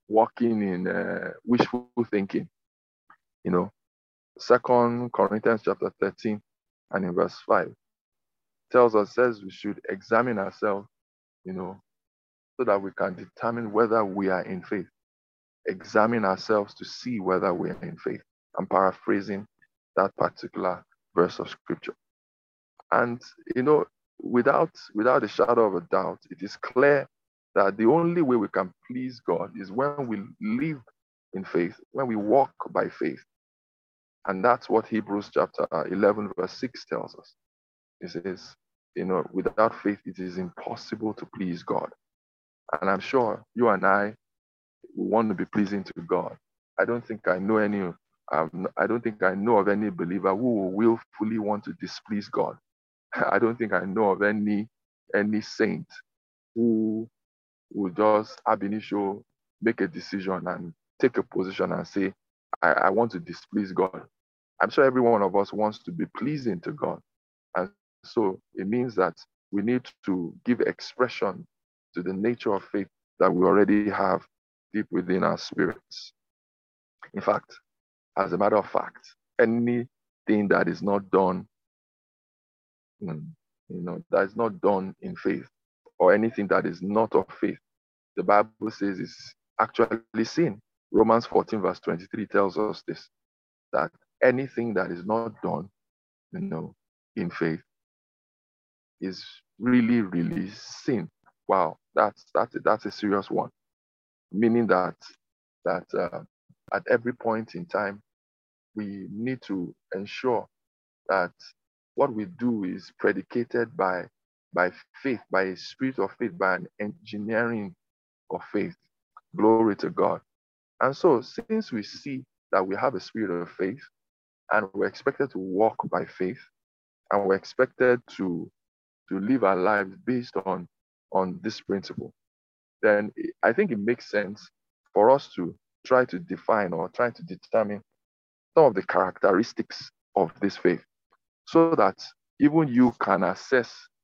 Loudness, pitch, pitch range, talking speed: -26 LUFS, 105 Hz, 90-115 Hz, 150 wpm